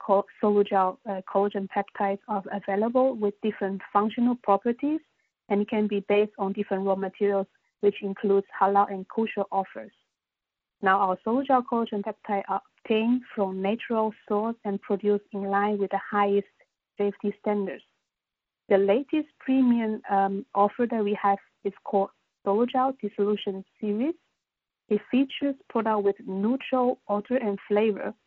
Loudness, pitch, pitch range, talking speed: -27 LUFS, 205 Hz, 200-225 Hz, 140 wpm